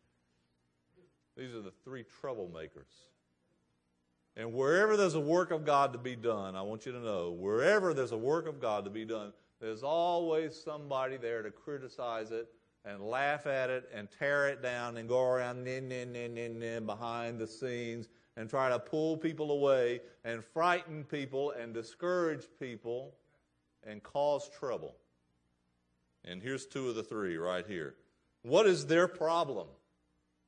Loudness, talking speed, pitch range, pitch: -34 LUFS, 165 wpm, 105-140 Hz, 120 Hz